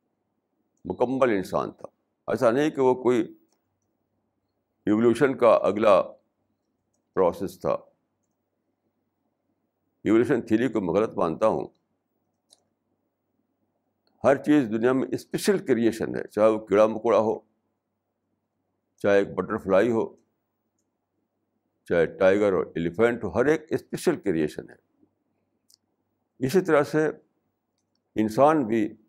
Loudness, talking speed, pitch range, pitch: -24 LUFS, 105 wpm, 110-130 Hz, 115 Hz